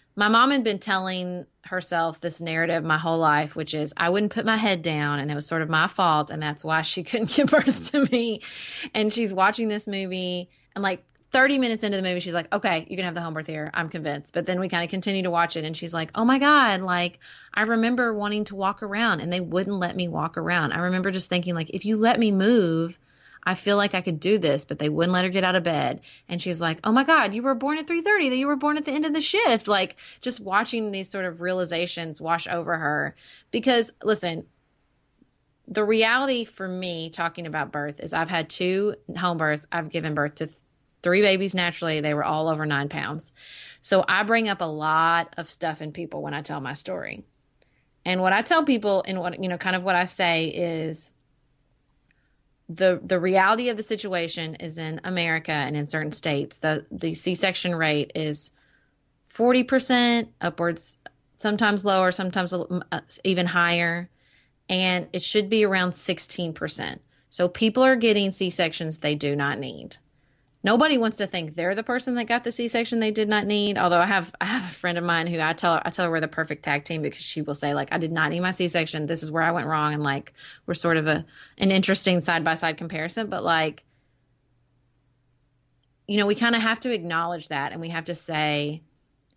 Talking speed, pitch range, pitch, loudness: 220 wpm, 160-205 Hz, 175 Hz, -24 LUFS